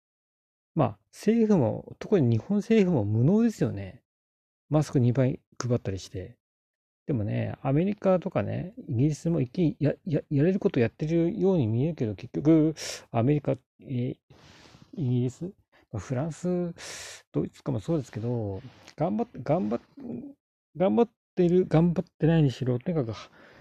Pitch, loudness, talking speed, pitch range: 150 Hz, -27 LUFS, 290 characters per minute, 120-180 Hz